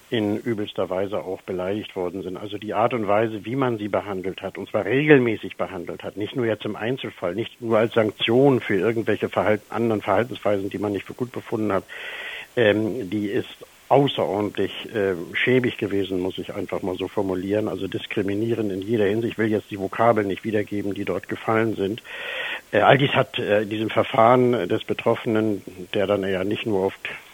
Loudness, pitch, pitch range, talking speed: -23 LUFS, 105 Hz, 100-115 Hz, 195 wpm